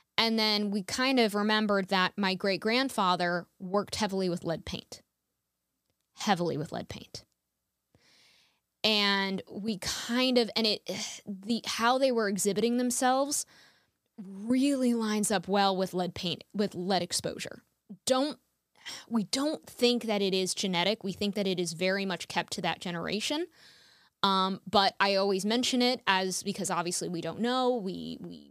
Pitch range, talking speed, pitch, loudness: 185-230 Hz, 155 wpm, 200 Hz, -29 LUFS